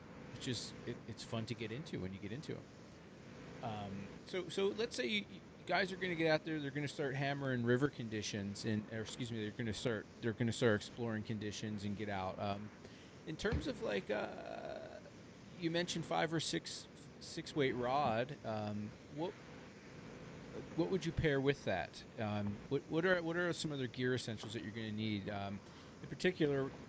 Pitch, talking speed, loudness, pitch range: 120 Hz, 205 wpm, -40 LUFS, 105-155 Hz